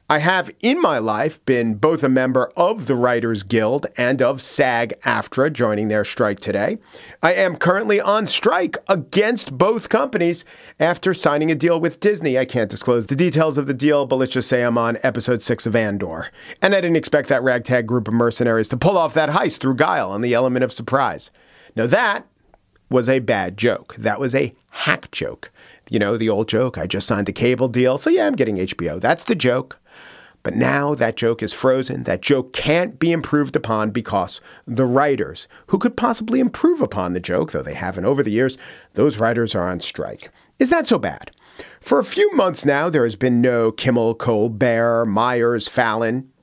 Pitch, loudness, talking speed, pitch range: 130 Hz, -19 LUFS, 200 wpm, 115-160 Hz